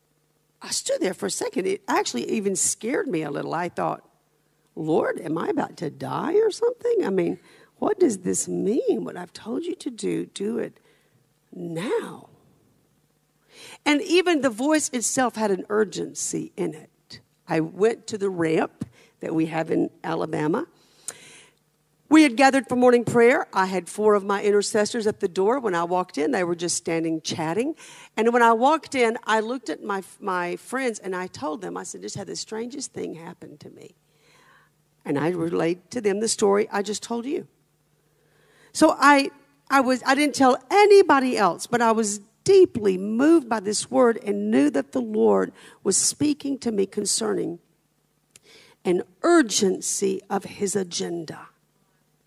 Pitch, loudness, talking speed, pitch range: 220 Hz, -23 LUFS, 170 wpm, 190-275 Hz